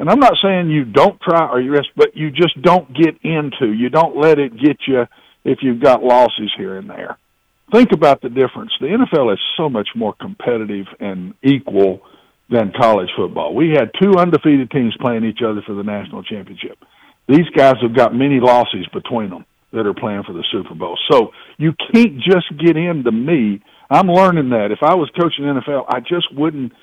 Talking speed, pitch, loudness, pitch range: 200 wpm, 140 Hz, -15 LUFS, 120-170 Hz